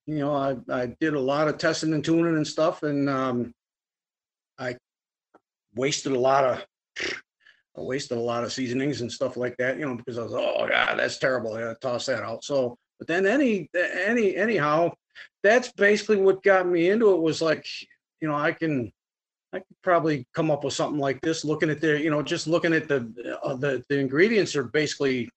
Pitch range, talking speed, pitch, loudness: 130-165 Hz, 205 wpm, 150 Hz, -25 LUFS